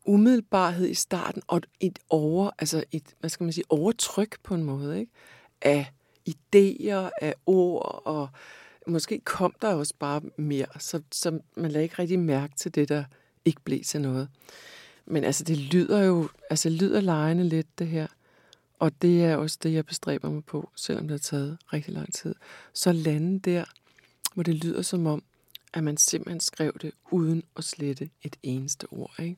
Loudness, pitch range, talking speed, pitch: -27 LUFS, 150-180 Hz, 180 wpm, 160 Hz